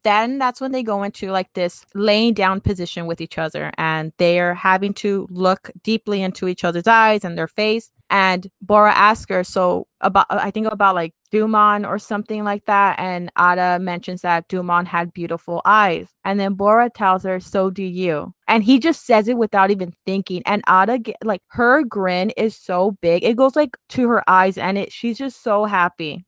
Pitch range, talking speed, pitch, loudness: 180-215 Hz, 200 wpm, 195 Hz, -18 LUFS